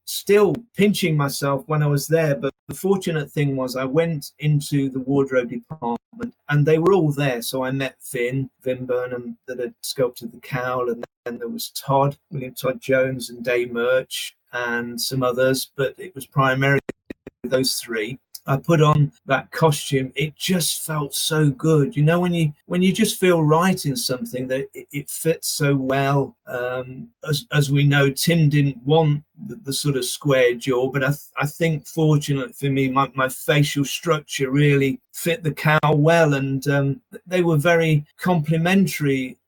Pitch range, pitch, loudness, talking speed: 130-160 Hz, 140 Hz, -21 LUFS, 180 wpm